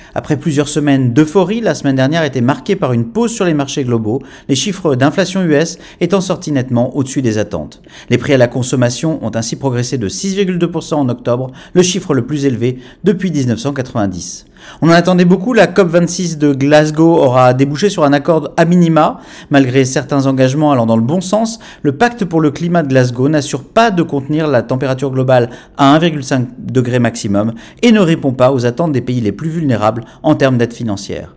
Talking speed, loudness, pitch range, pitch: 195 wpm, -13 LUFS, 125-170 Hz, 145 Hz